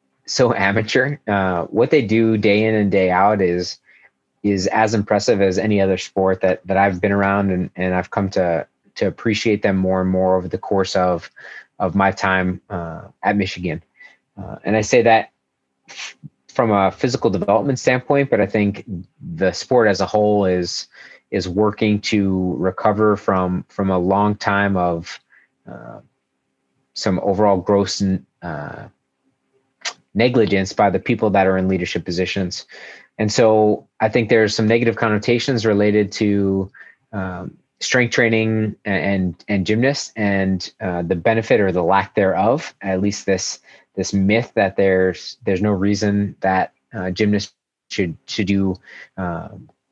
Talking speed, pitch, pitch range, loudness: 155 wpm, 100 Hz, 95-105 Hz, -18 LUFS